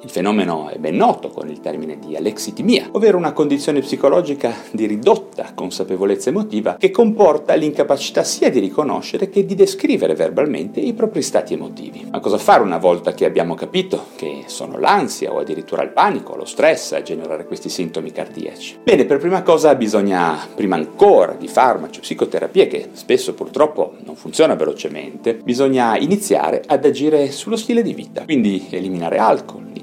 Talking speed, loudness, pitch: 165 wpm, -17 LUFS, 220 Hz